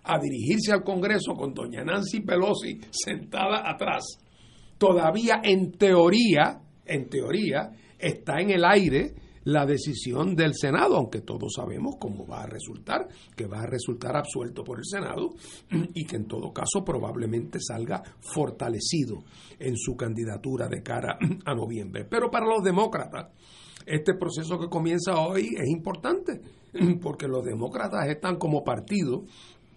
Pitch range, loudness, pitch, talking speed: 125-190 Hz, -27 LUFS, 165 Hz, 140 wpm